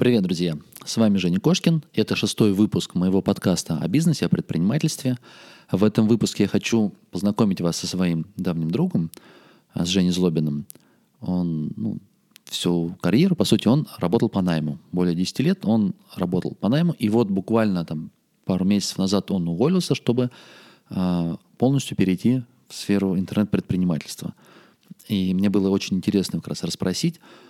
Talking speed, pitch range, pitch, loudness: 150 wpm, 90-120 Hz, 100 Hz, -22 LUFS